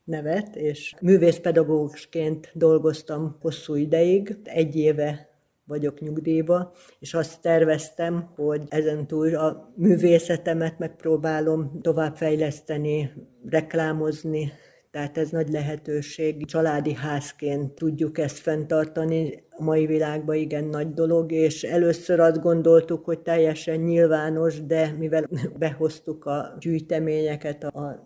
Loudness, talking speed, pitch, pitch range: -24 LUFS, 105 wpm, 160 Hz, 150-165 Hz